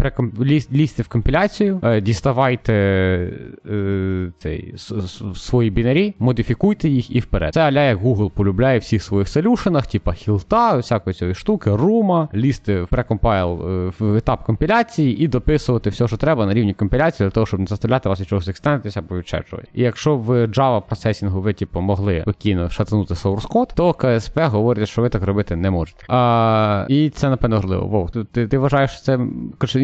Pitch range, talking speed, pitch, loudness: 100-135 Hz, 160 wpm, 115 Hz, -19 LUFS